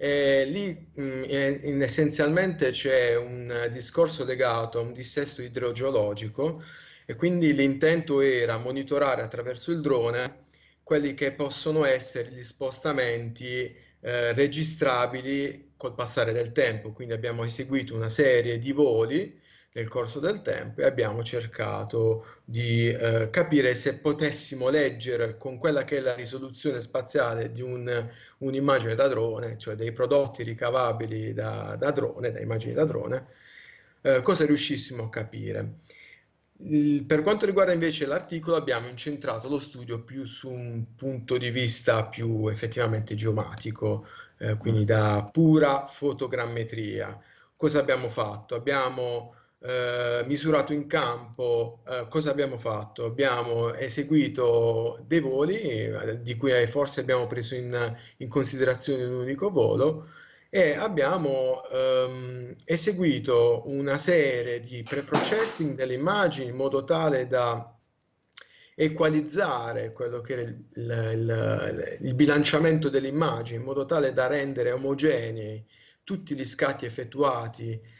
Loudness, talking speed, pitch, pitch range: -27 LUFS, 125 wpm, 130 Hz, 115-145 Hz